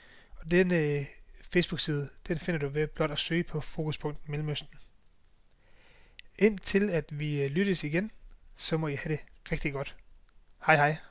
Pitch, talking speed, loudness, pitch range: 155 Hz, 150 wpm, -30 LUFS, 145-175 Hz